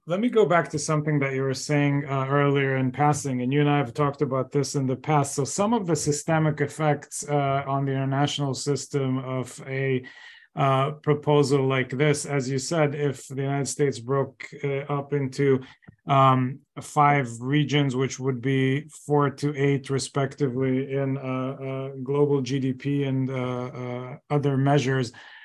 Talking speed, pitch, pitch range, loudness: 170 wpm, 140 Hz, 135-145 Hz, -25 LUFS